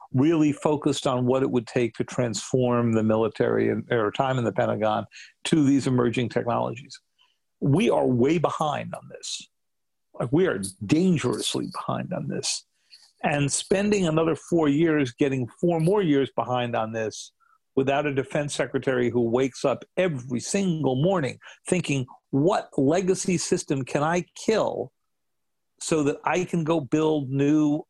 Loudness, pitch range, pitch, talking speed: -24 LUFS, 125-165 Hz, 140 Hz, 150 wpm